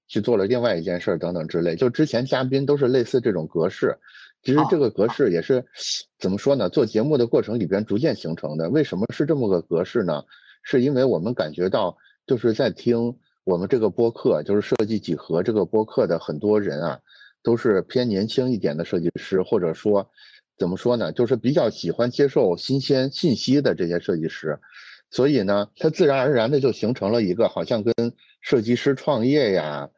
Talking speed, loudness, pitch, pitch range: 310 characters per minute, -22 LUFS, 115 Hz, 95-130 Hz